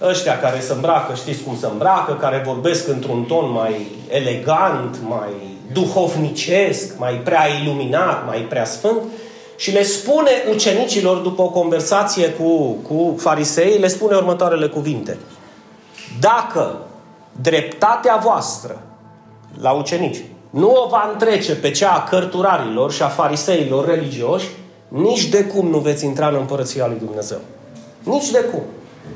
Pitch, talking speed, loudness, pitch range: 165 Hz, 135 wpm, -17 LUFS, 140-195 Hz